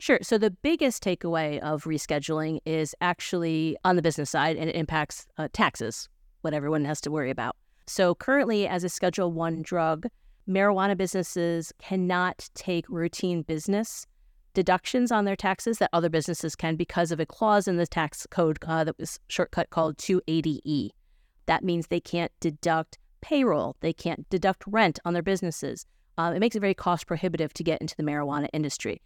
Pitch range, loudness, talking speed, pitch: 160-190 Hz, -27 LUFS, 175 wpm, 170 Hz